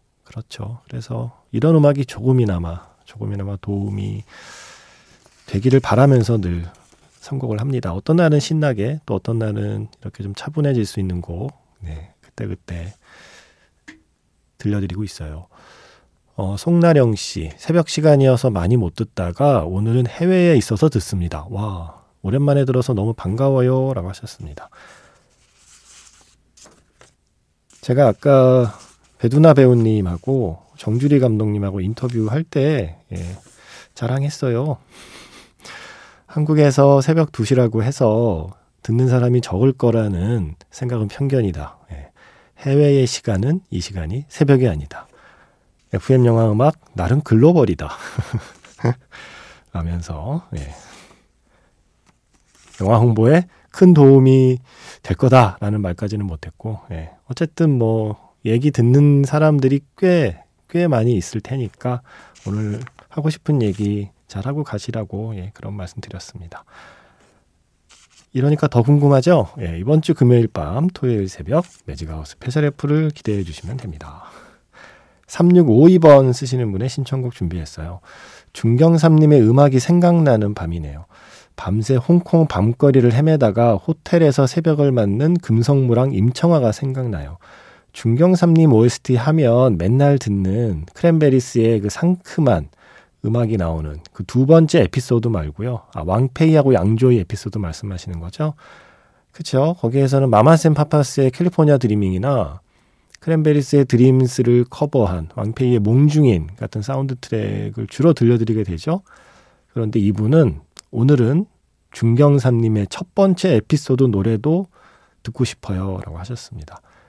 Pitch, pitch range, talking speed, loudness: 120 Hz, 100-140 Hz, 285 characters per minute, -17 LUFS